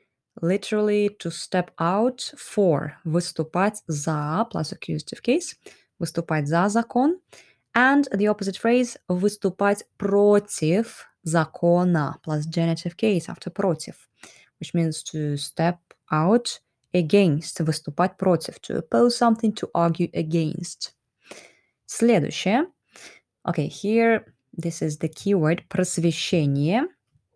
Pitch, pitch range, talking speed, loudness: 180 Hz, 165-210 Hz, 105 wpm, -23 LUFS